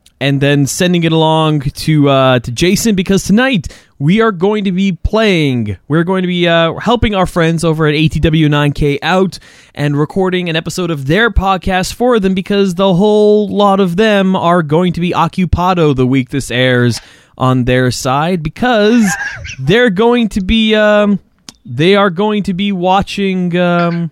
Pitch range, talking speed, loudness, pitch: 150-200 Hz, 170 wpm, -12 LUFS, 175 Hz